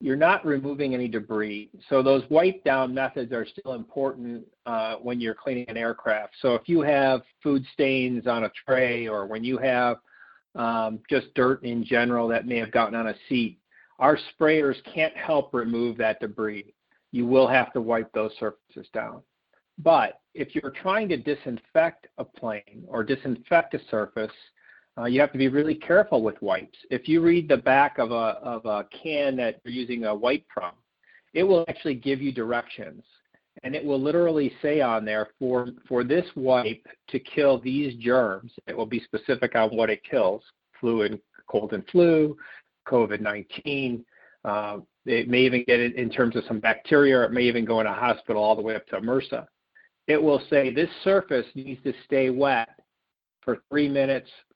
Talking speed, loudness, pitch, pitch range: 185 wpm, -25 LUFS, 125 Hz, 115-140 Hz